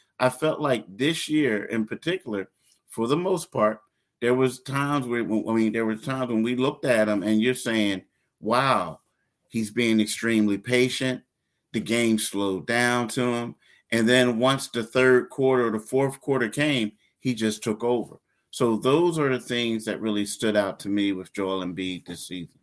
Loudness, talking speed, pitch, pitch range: -24 LUFS, 185 wpm, 115 Hz, 110-130 Hz